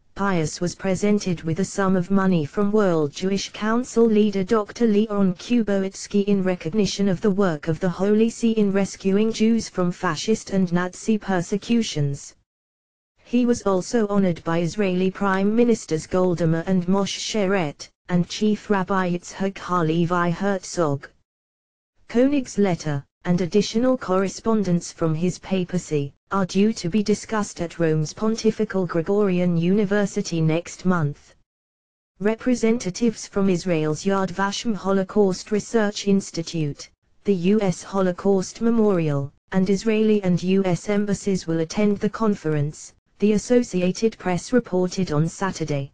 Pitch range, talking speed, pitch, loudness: 170-210 Hz, 130 wpm, 190 Hz, -22 LUFS